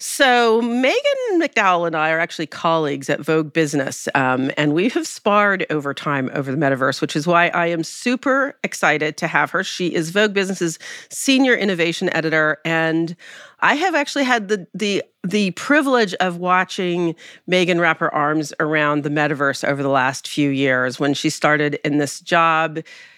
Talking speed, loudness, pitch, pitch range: 175 wpm, -18 LUFS, 165 Hz, 150-200 Hz